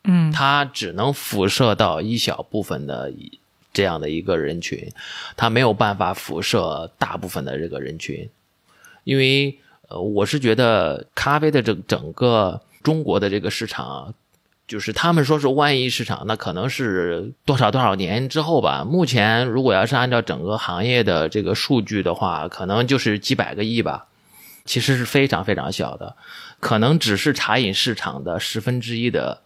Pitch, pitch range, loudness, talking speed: 115 Hz, 105-135 Hz, -20 LUFS, 260 characters per minute